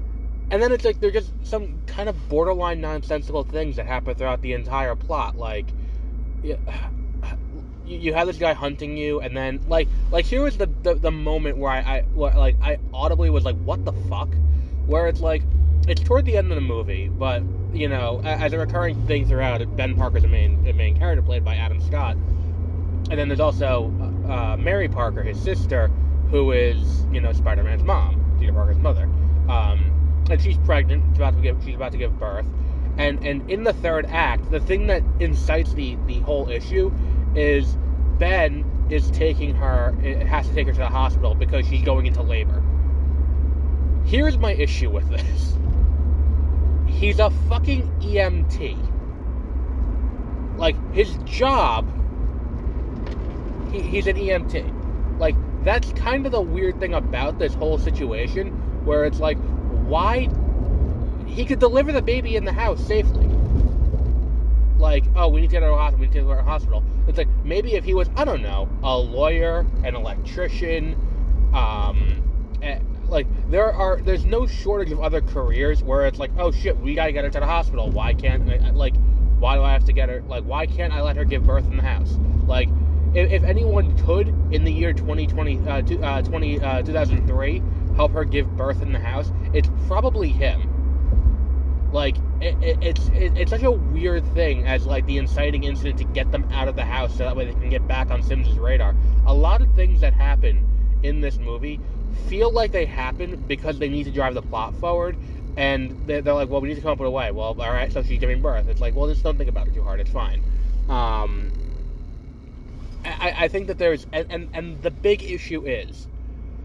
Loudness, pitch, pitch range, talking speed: -22 LUFS, 75 Hz, 70-95 Hz, 190 wpm